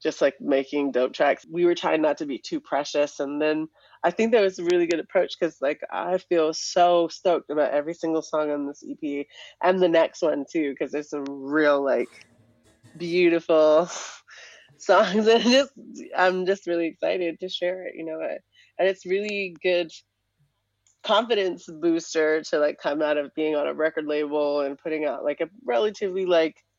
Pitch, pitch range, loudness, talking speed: 165 Hz, 145-180 Hz, -24 LUFS, 185 wpm